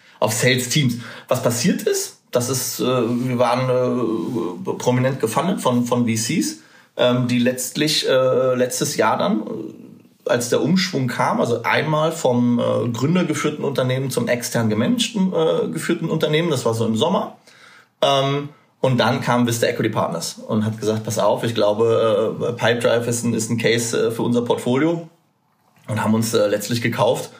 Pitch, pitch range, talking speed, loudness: 125 Hz, 120-150 Hz, 140 wpm, -20 LUFS